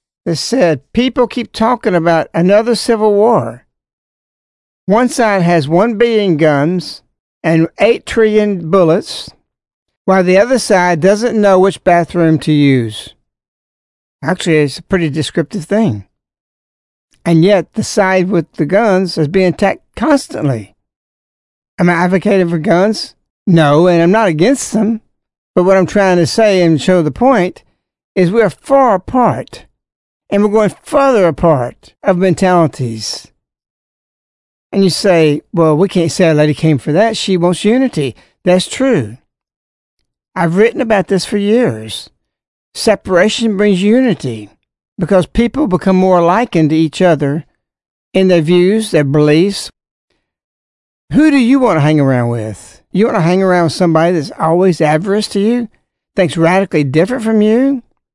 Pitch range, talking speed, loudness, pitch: 155-210 Hz, 145 wpm, -12 LUFS, 180 Hz